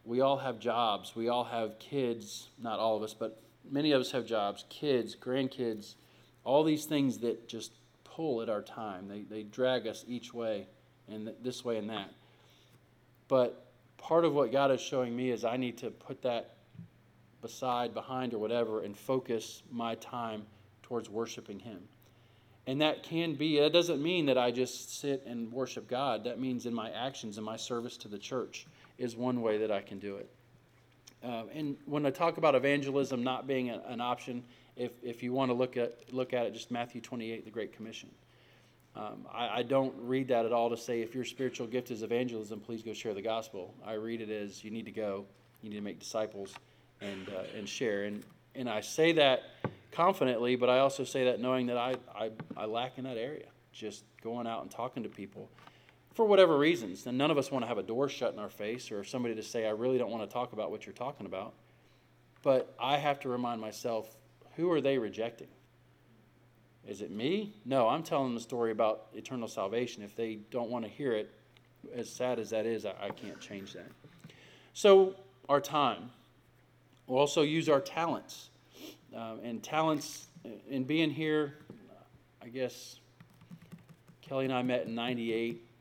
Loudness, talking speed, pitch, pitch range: -34 LUFS, 195 wpm, 120 Hz, 110-130 Hz